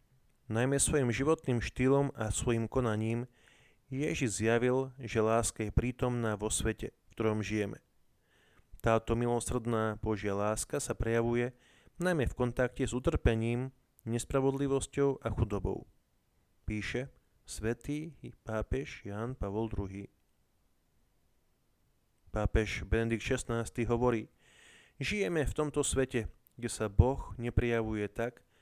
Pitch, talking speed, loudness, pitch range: 115 Hz, 105 wpm, -33 LUFS, 110-130 Hz